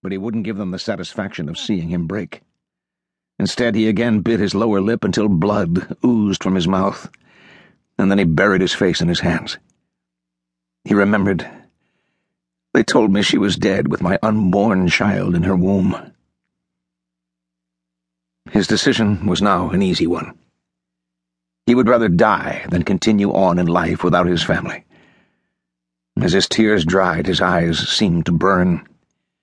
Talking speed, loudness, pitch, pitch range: 155 wpm, -17 LUFS, 85 Hz, 60-95 Hz